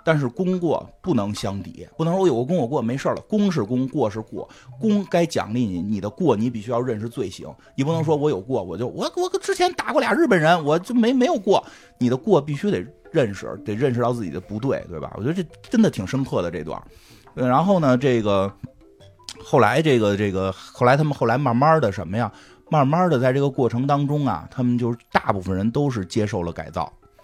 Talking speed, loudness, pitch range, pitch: 330 characters per minute, -22 LUFS, 105-160 Hz, 130 Hz